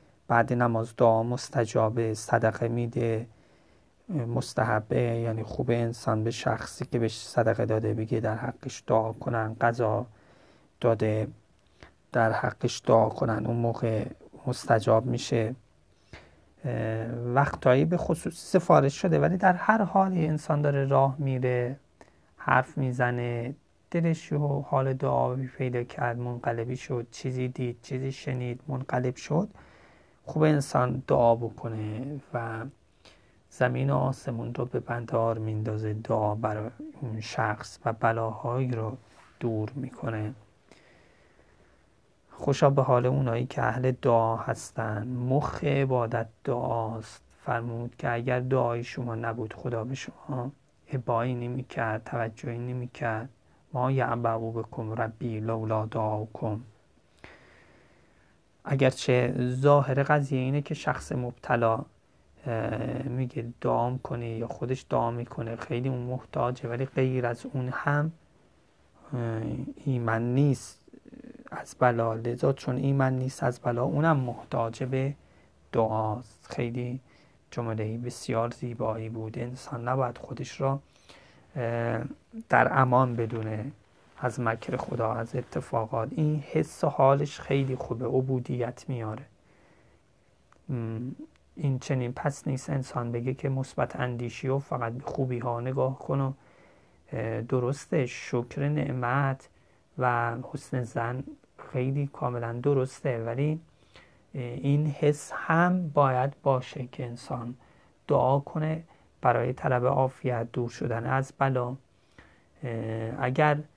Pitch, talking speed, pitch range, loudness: 125 Hz, 115 wpm, 115-135 Hz, -29 LUFS